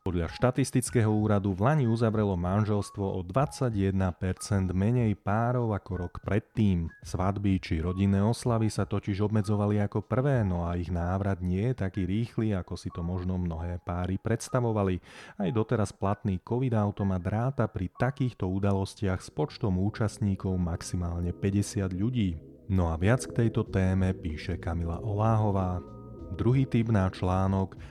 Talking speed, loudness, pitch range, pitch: 140 wpm, -29 LUFS, 95-110 Hz, 100 Hz